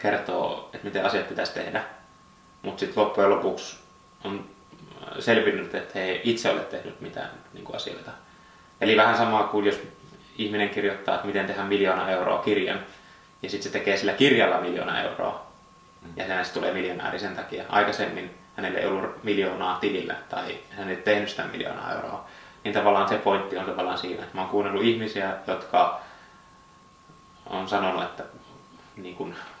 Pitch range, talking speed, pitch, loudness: 100-105 Hz, 155 wpm, 100 Hz, -26 LUFS